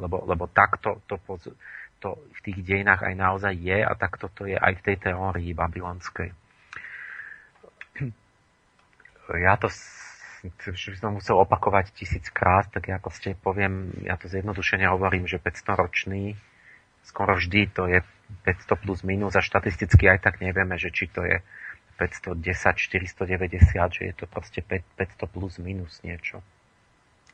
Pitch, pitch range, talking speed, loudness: 95 Hz, 90-100 Hz, 140 wpm, -25 LUFS